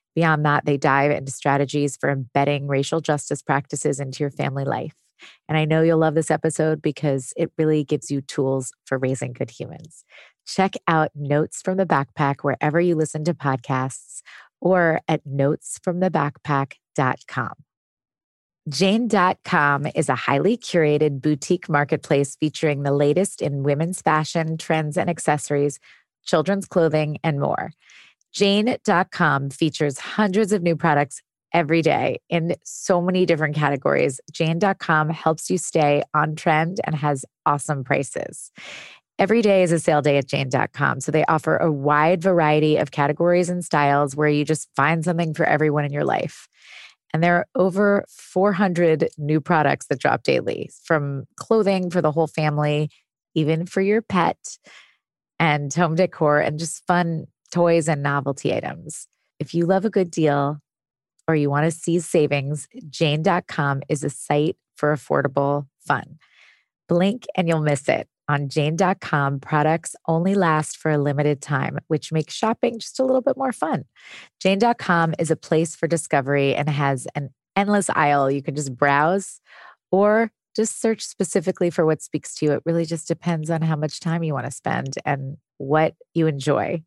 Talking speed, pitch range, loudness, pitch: 160 wpm, 145-175 Hz, -21 LUFS, 155 Hz